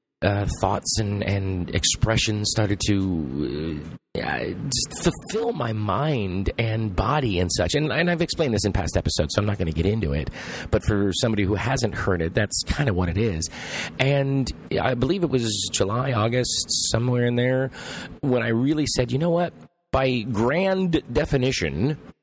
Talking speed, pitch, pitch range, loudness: 175 wpm, 110 Hz, 100-130 Hz, -23 LUFS